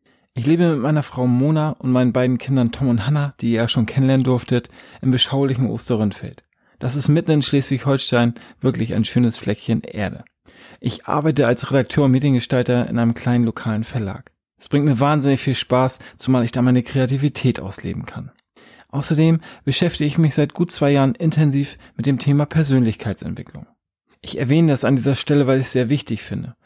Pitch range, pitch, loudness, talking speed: 120-145 Hz, 130 Hz, -19 LUFS, 180 wpm